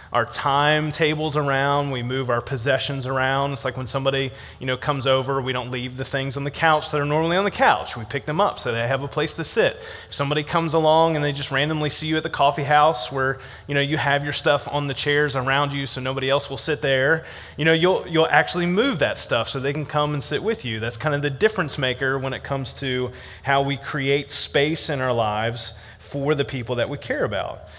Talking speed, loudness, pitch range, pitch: 245 wpm, -21 LUFS, 130-150 Hz, 140 Hz